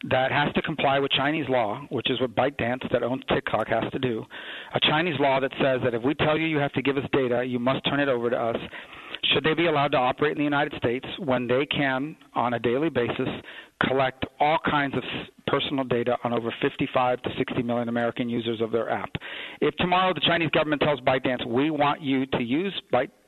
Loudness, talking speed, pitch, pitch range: -25 LUFS, 225 wpm, 135 Hz, 125-150 Hz